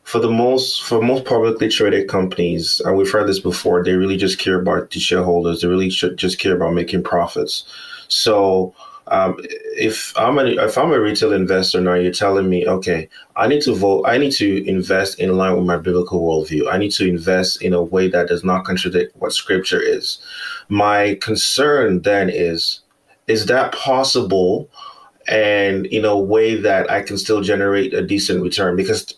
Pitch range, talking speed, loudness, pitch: 90-110 Hz, 190 wpm, -17 LUFS, 95 Hz